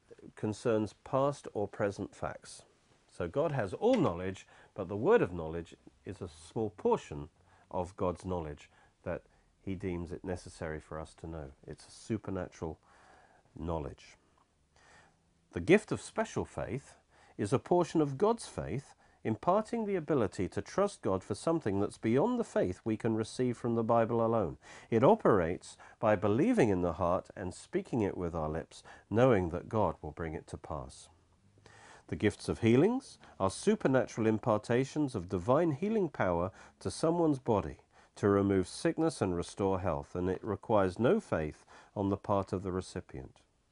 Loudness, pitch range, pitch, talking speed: -33 LUFS, 90-120 Hz, 100 Hz, 160 wpm